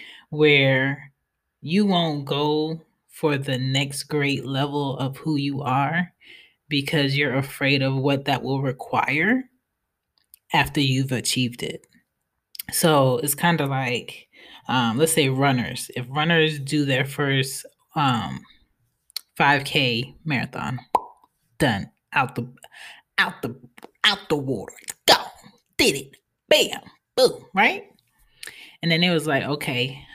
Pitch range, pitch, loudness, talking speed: 135-155 Hz, 140 Hz, -22 LUFS, 125 wpm